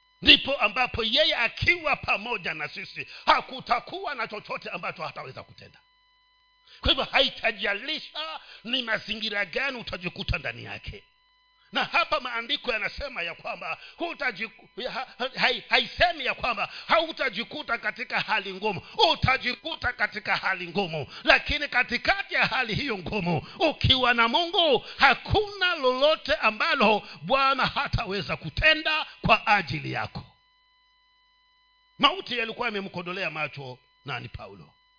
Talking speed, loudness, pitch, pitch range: 110 wpm, -25 LUFS, 260 Hz, 215-340 Hz